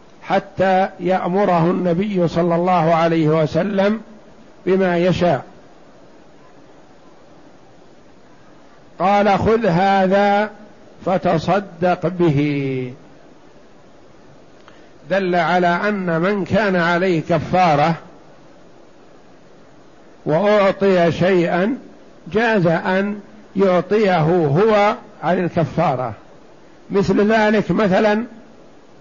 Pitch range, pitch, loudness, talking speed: 170-200 Hz, 185 Hz, -17 LUFS, 65 wpm